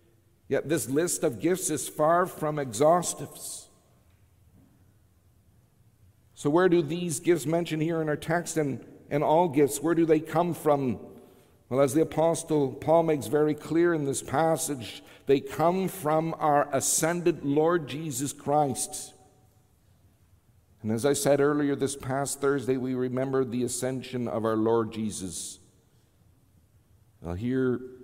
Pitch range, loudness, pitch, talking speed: 110-155 Hz, -27 LUFS, 140 Hz, 140 wpm